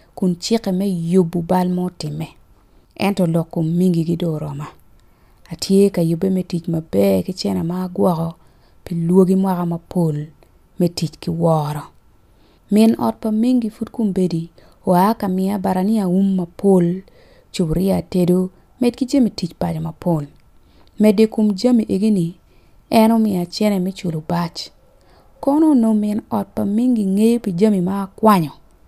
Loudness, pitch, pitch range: -18 LUFS, 185 Hz, 165-210 Hz